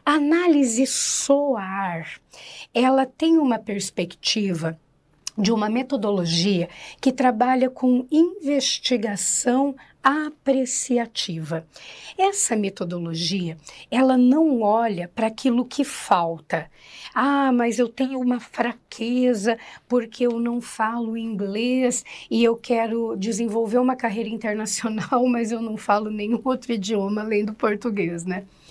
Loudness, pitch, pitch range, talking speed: -22 LUFS, 235 Hz, 210-260 Hz, 110 wpm